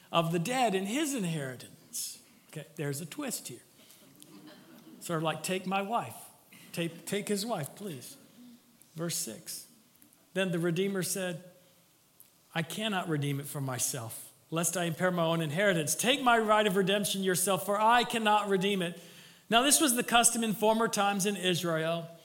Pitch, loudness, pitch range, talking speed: 185 Hz, -30 LUFS, 165-210 Hz, 165 wpm